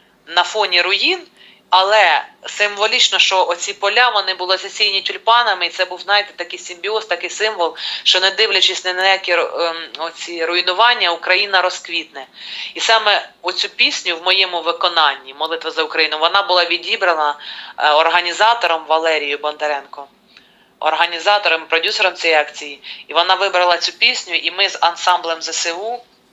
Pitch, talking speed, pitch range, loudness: 180 Hz, 140 wpm, 165-195 Hz, -15 LUFS